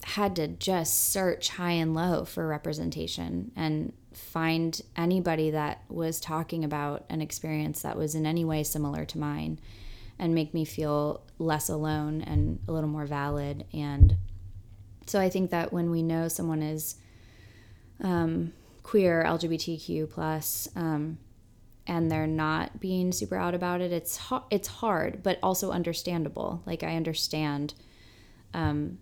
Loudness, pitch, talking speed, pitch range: -30 LUFS, 155 Hz, 145 wpm, 145-170 Hz